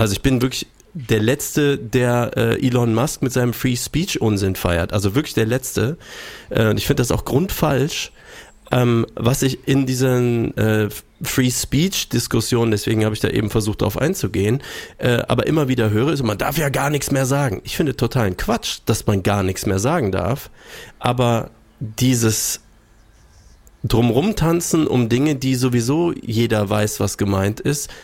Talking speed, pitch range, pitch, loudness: 170 wpm, 110-135 Hz, 120 Hz, -19 LUFS